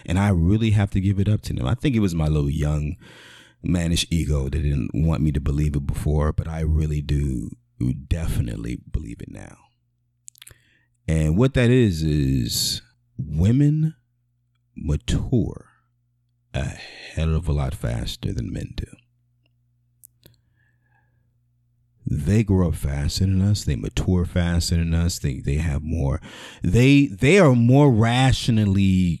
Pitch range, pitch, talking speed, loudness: 80-120 Hz, 100 Hz, 145 wpm, -22 LUFS